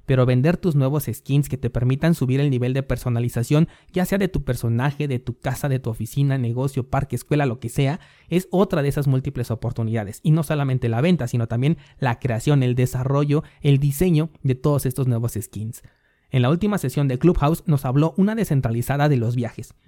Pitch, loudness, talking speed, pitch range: 135 Hz, -22 LUFS, 200 wpm, 120-150 Hz